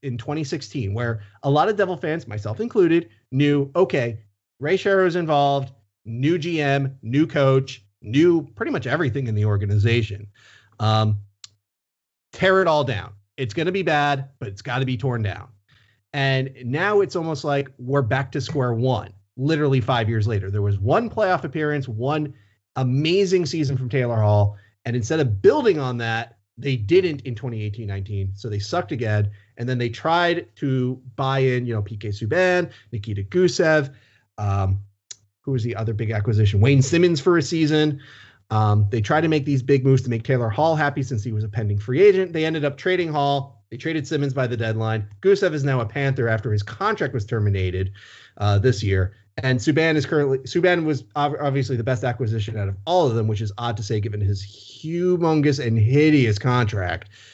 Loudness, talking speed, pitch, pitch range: -22 LUFS, 185 wpm, 130 Hz, 110-150 Hz